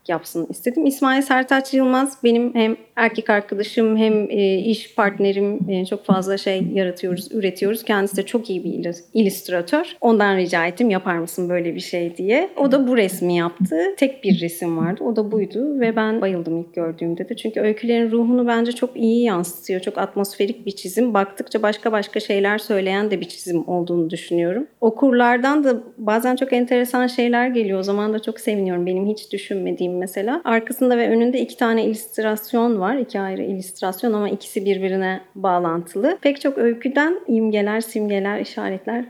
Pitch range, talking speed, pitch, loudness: 190-235 Hz, 165 wpm, 210 Hz, -20 LUFS